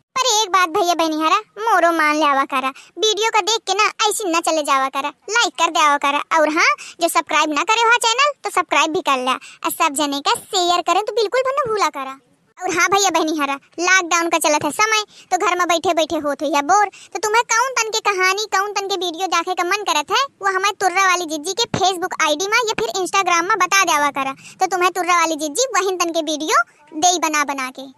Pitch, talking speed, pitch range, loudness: 355 Hz, 225 wpm, 310-400 Hz, -17 LUFS